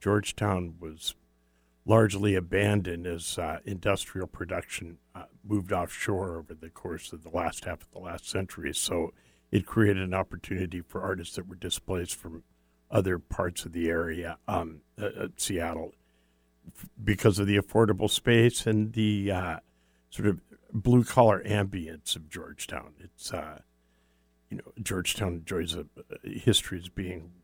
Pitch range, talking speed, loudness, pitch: 80-105 Hz, 145 wpm, -29 LUFS, 90 Hz